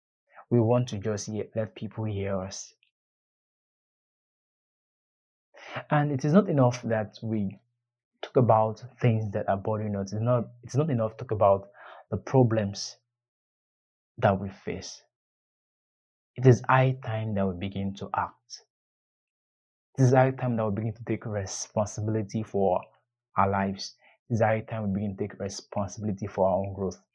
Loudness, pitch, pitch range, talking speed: -28 LUFS, 110 Hz, 100-120 Hz, 155 wpm